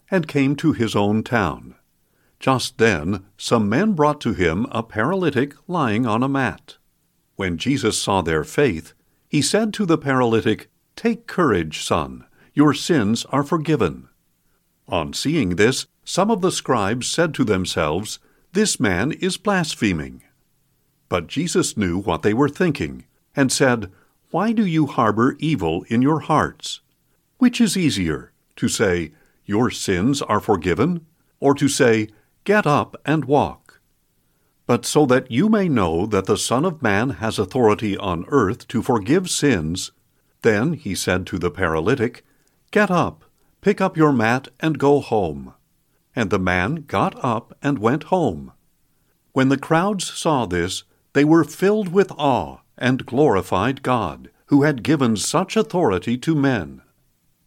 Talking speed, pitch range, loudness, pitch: 150 wpm, 105-155 Hz, -20 LUFS, 135 Hz